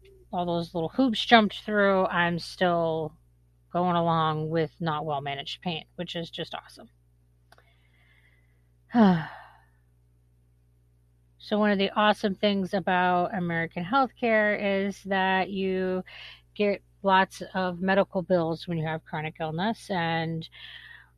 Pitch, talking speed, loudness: 170 Hz, 120 wpm, -26 LUFS